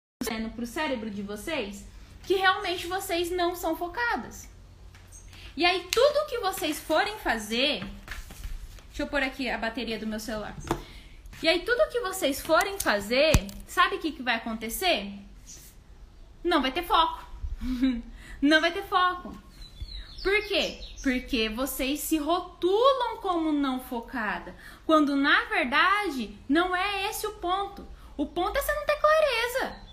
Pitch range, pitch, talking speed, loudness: 240-360 Hz, 305 Hz, 140 wpm, -27 LUFS